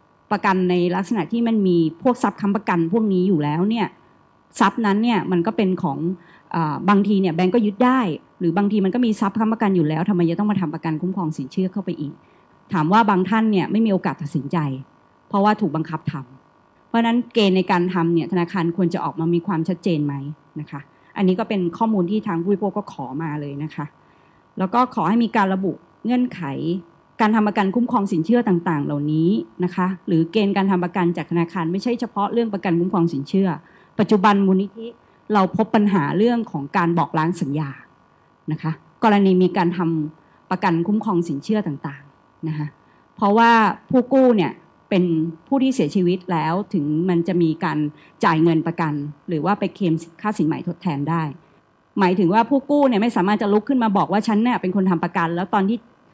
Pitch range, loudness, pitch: 165-210 Hz, -20 LUFS, 185 Hz